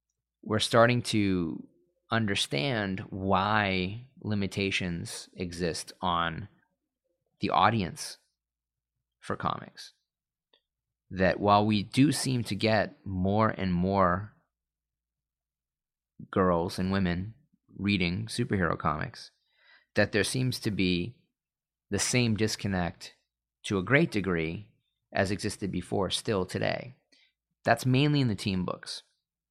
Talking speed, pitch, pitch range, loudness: 105 wpm, 100 Hz, 90-115 Hz, -29 LUFS